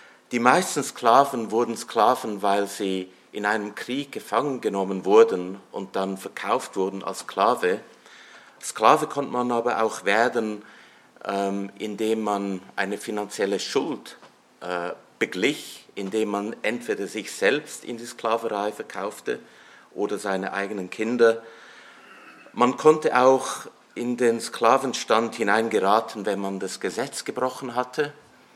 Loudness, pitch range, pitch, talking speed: -24 LUFS, 100-120 Hz, 110 Hz, 120 wpm